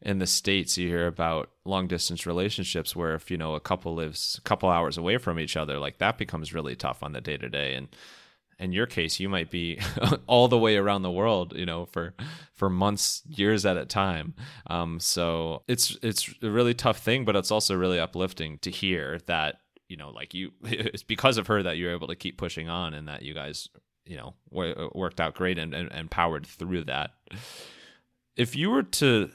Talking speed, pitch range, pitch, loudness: 215 wpm, 85-105 Hz, 90 Hz, -27 LUFS